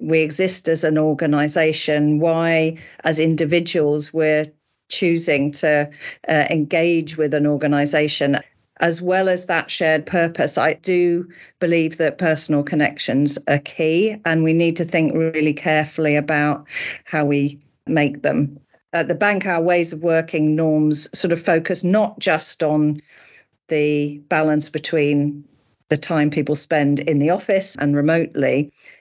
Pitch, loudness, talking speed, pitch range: 155 Hz, -19 LUFS, 140 wpm, 150-165 Hz